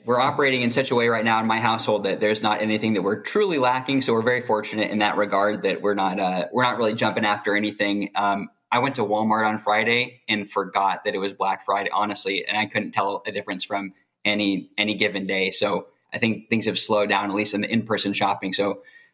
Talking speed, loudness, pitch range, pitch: 240 wpm, -22 LUFS, 100-110 Hz, 105 Hz